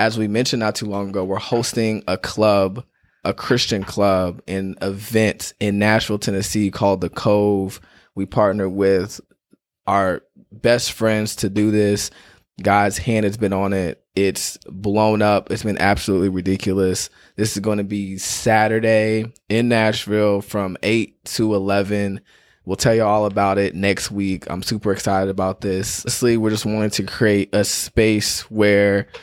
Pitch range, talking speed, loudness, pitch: 95-110 Hz, 160 wpm, -19 LUFS, 100 Hz